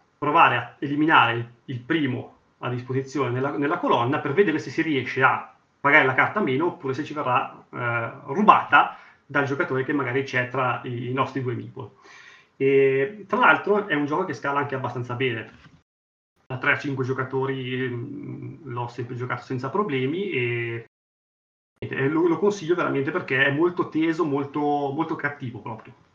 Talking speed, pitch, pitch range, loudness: 165 wpm, 135 Hz, 125-150 Hz, -23 LUFS